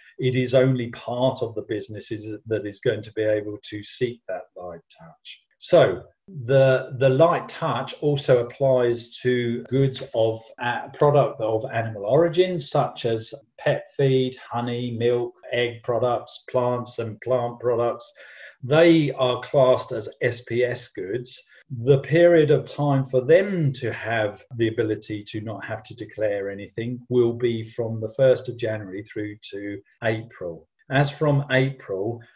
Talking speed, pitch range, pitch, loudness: 150 wpm, 110-135 Hz, 125 Hz, -23 LUFS